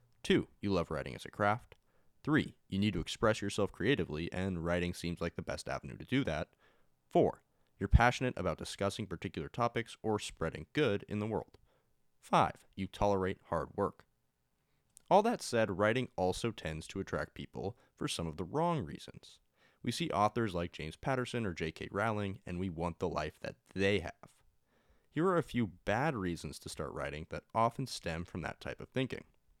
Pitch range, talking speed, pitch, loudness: 85-115 Hz, 185 wpm, 95 Hz, -36 LUFS